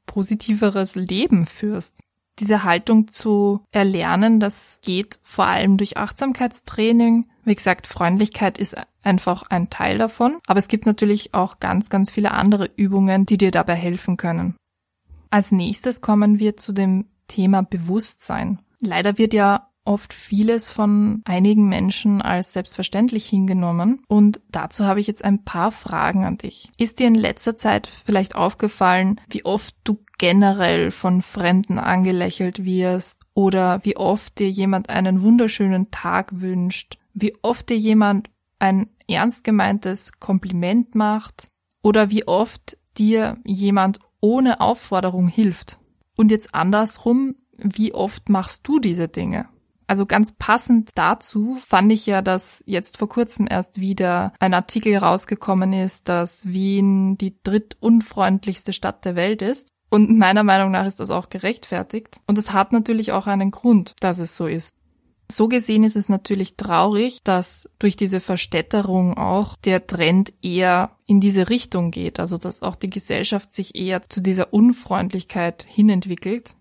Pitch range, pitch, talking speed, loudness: 185-215 Hz, 200 Hz, 145 wpm, -19 LUFS